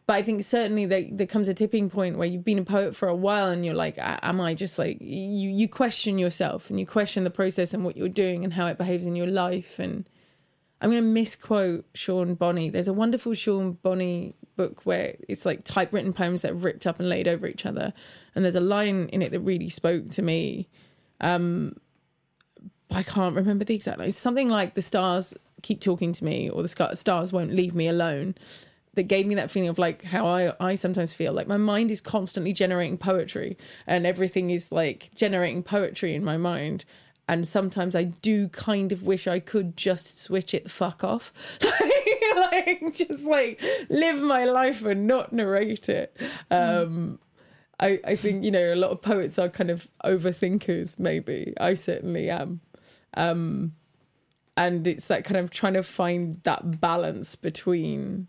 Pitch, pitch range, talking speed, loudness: 185 Hz, 175-205 Hz, 195 wpm, -26 LUFS